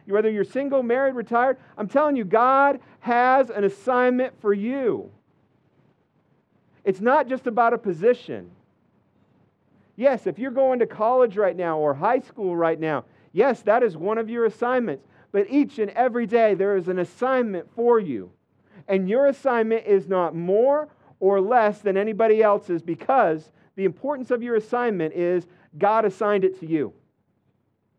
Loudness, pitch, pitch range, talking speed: -22 LUFS, 220 Hz, 190-250 Hz, 160 wpm